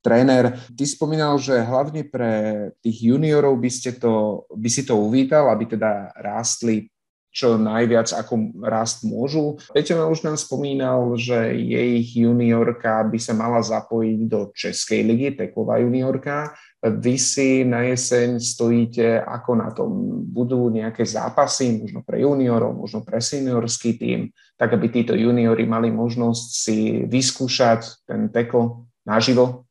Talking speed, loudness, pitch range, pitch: 140 wpm, -20 LUFS, 115-130 Hz, 120 Hz